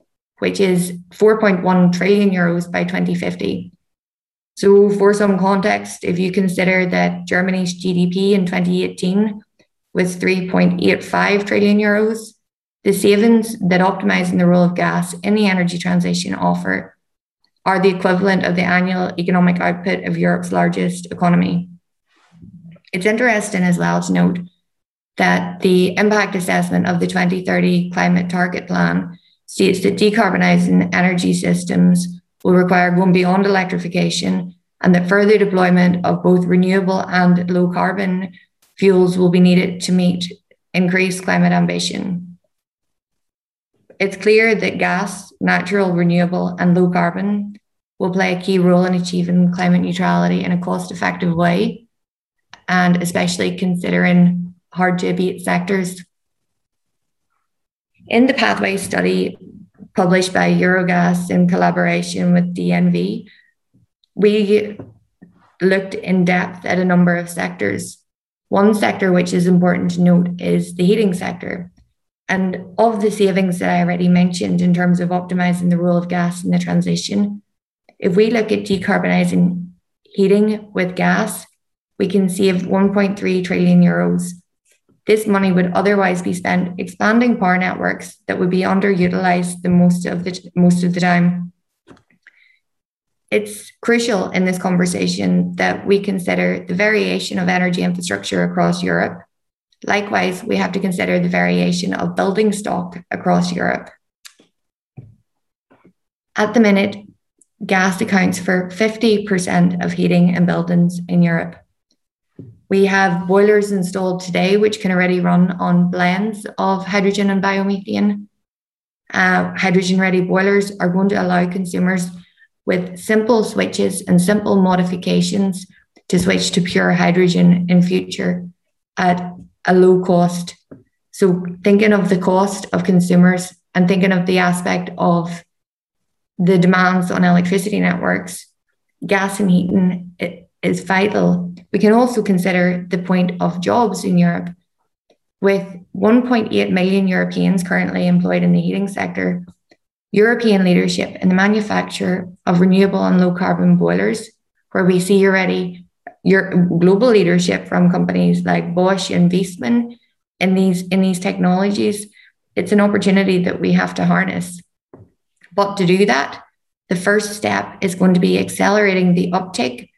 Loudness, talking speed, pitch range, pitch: -16 LUFS, 135 wpm, 175-195 Hz, 180 Hz